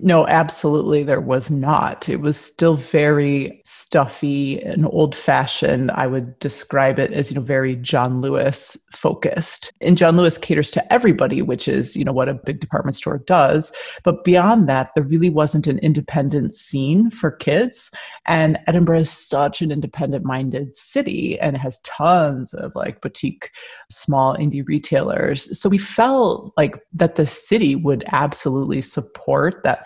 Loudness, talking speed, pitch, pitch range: -18 LUFS, 155 wpm, 150 Hz, 140-170 Hz